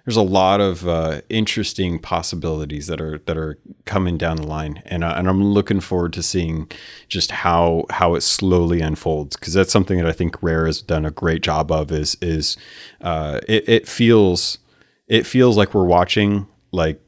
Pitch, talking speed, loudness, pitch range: 85 Hz, 190 wpm, -19 LUFS, 80-100 Hz